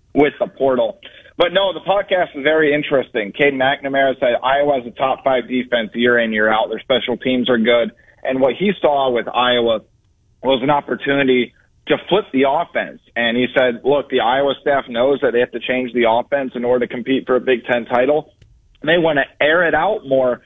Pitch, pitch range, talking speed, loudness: 125 Hz, 120-140 Hz, 210 wpm, -17 LUFS